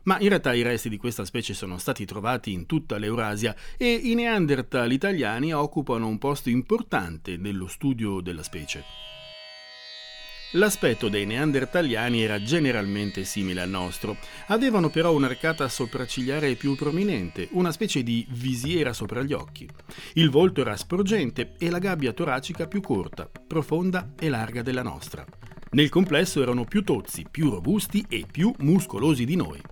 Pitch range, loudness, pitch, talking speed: 105-160 Hz, -25 LUFS, 130 Hz, 150 wpm